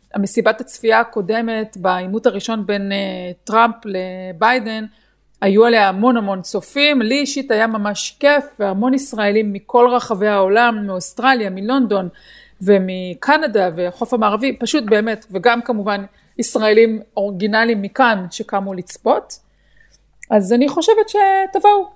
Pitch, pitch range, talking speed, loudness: 220 Hz, 200-245 Hz, 110 wpm, -16 LUFS